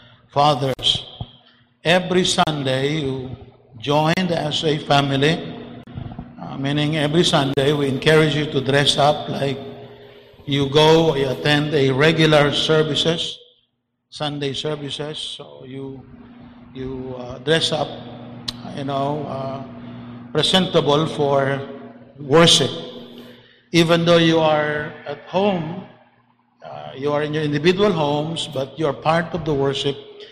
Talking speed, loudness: 120 wpm, -19 LUFS